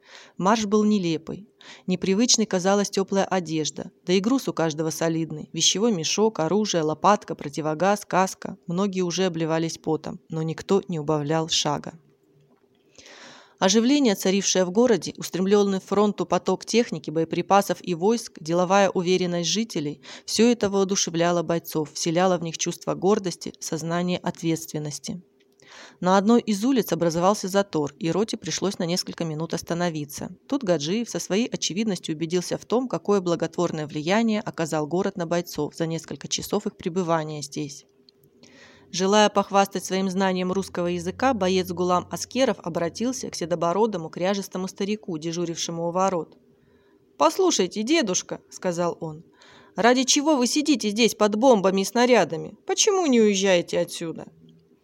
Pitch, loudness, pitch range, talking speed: 185 Hz, -23 LUFS, 165-205 Hz, 135 wpm